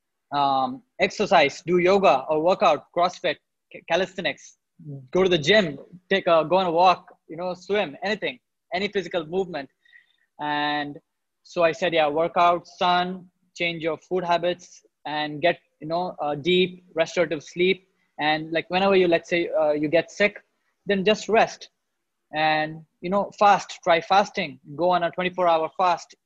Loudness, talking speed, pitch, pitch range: -23 LUFS, 160 wpm, 175 Hz, 165-190 Hz